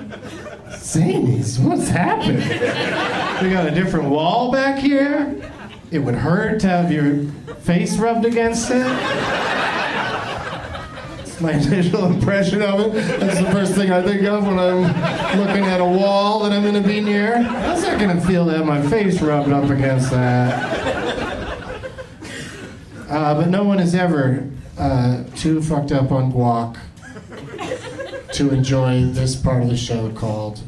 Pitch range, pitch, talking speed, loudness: 135-200 Hz, 175 Hz, 155 wpm, -18 LUFS